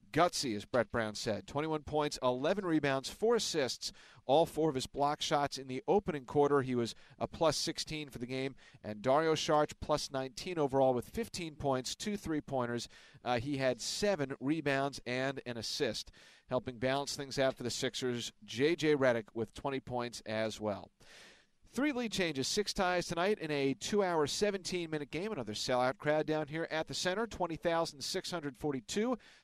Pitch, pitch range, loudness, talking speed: 145 Hz, 130-160 Hz, -35 LUFS, 175 wpm